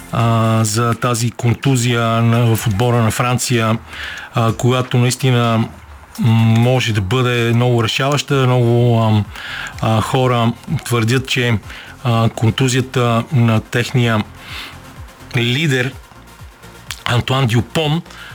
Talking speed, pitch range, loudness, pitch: 80 wpm, 115-125 Hz, -16 LUFS, 120 Hz